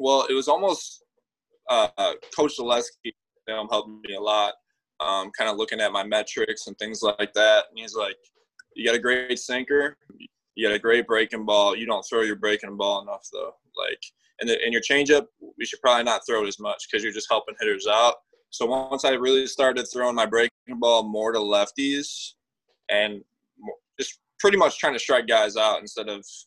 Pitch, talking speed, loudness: 135 Hz, 195 wpm, -23 LUFS